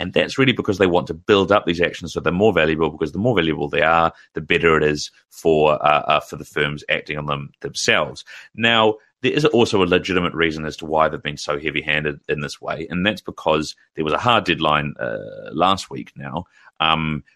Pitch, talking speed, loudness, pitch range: 80 Hz, 225 wpm, -19 LUFS, 75-90 Hz